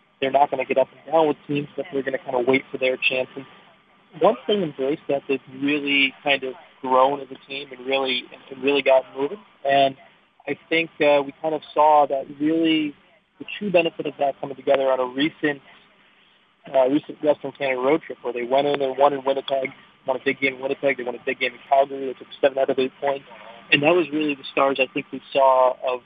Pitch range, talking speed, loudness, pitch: 130-145 Hz, 240 wpm, -22 LUFS, 135 Hz